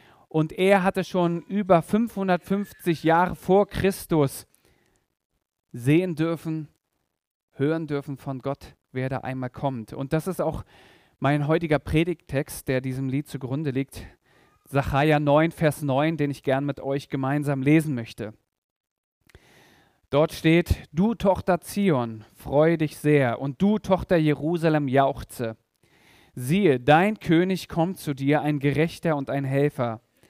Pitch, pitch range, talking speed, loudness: 150 Hz, 135-170 Hz, 135 wpm, -24 LUFS